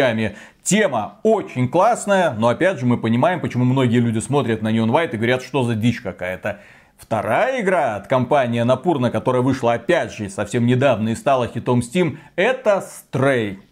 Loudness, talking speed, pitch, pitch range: -19 LUFS, 165 wpm, 120 Hz, 115-135 Hz